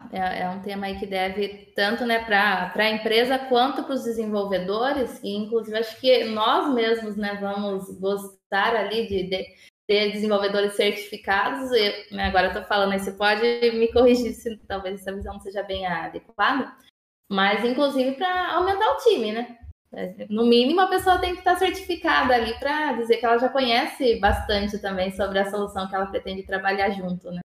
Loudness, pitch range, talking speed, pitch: -23 LUFS, 200-245 Hz, 185 wpm, 215 Hz